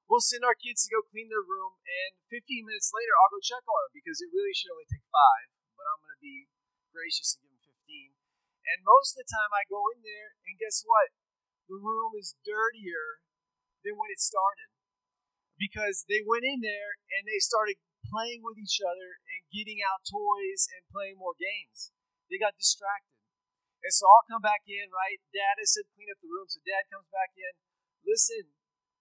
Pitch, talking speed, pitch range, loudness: 215 Hz, 205 wpm, 200-300 Hz, -28 LUFS